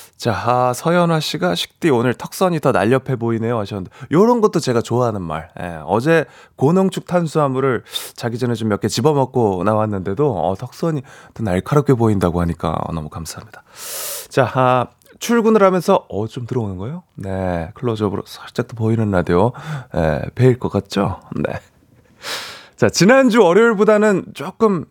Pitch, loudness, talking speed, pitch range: 125 Hz, -18 LUFS, 335 characters per minute, 105-165 Hz